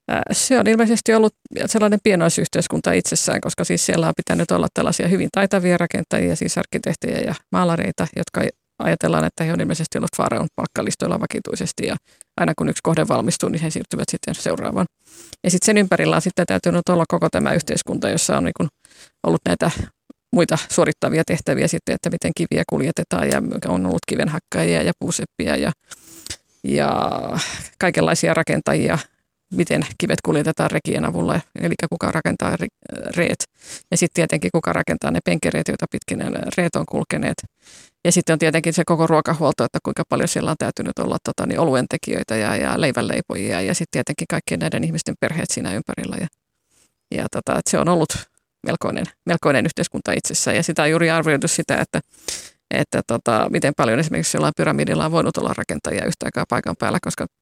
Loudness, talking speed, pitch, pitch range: -20 LUFS, 165 wpm, 170 Hz, 160-195 Hz